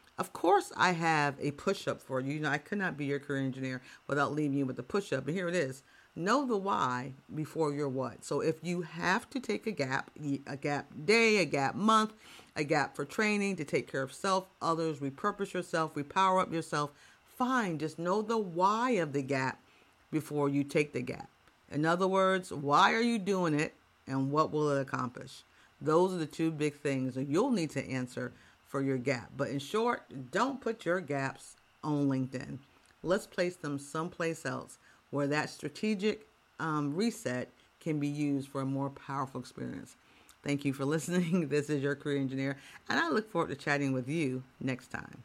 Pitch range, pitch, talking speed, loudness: 140-185 Hz, 150 Hz, 200 wpm, -33 LUFS